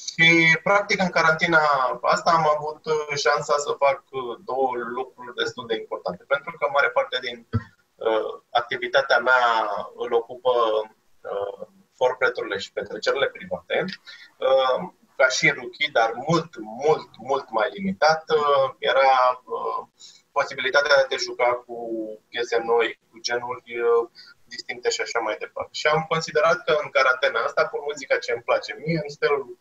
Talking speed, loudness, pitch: 145 wpm, -23 LUFS, 155 Hz